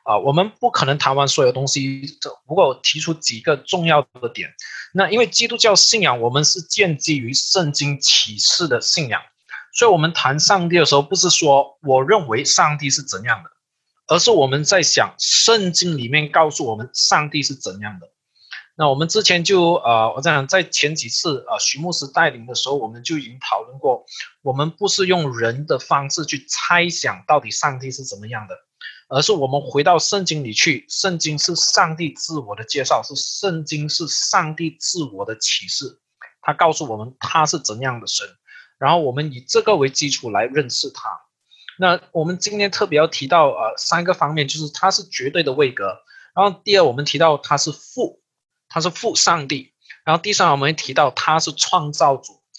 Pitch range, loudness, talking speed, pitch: 140-180 Hz, -17 LUFS, 285 characters per minute, 155 Hz